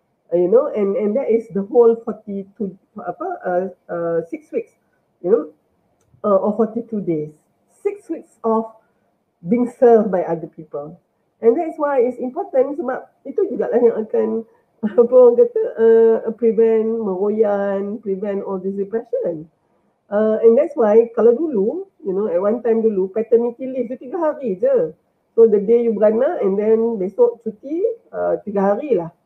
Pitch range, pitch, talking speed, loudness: 205-270 Hz, 225 Hz, 170 wpm, -18 LUFS